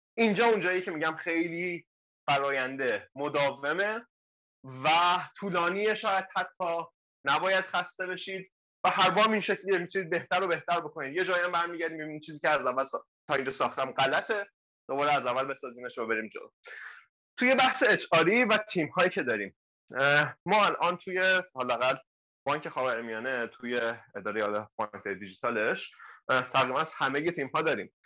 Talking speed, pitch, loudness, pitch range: 150 wpm, 175 Hz, -29 LUFS, 140-190 Hz